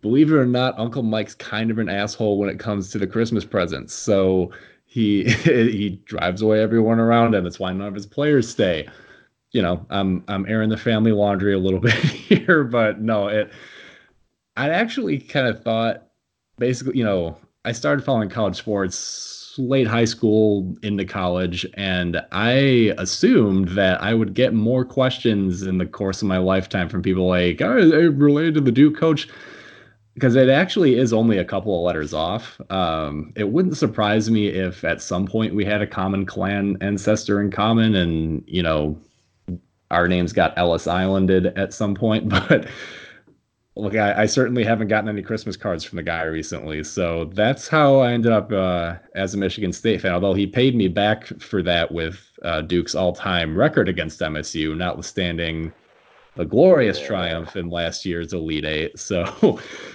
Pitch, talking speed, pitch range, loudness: 100 Hz, 175 wpm, 90-115 Hz, -20 LUFS